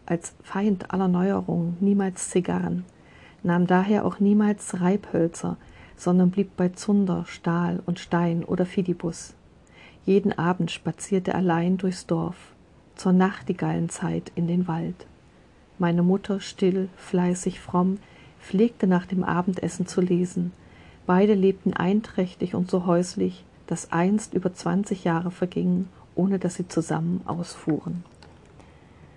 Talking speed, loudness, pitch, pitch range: 120 wpm, -25 LUFS, 180 Hz, 170-190 Hz